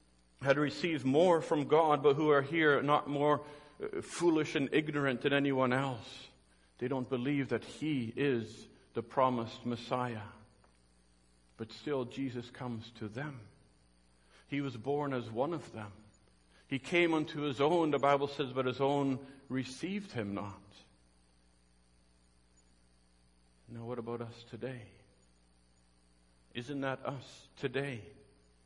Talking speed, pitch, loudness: 130 wpm, 125 Hz, -34 LUFS